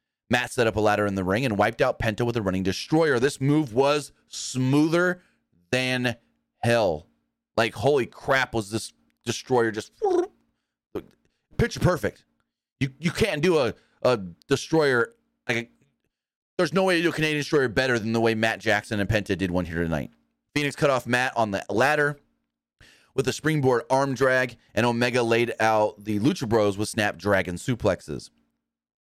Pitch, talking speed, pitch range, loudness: 120 Hz, 170 wpm, 105-145 Hz, -24 LUFS